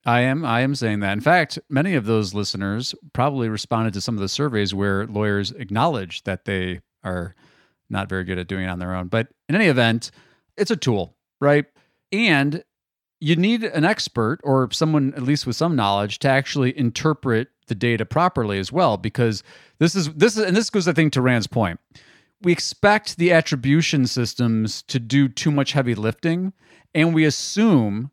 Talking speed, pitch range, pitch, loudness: 190 wpm, 110-160 Hz, 130 Hz, -21 LUFS